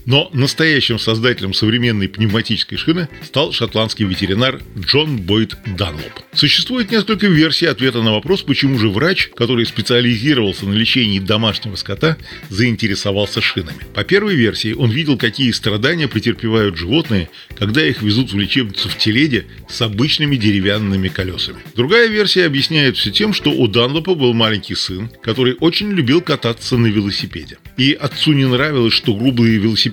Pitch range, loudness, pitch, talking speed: 110-145 Hz, -15 LUFS, 120 Hz, 145 wpm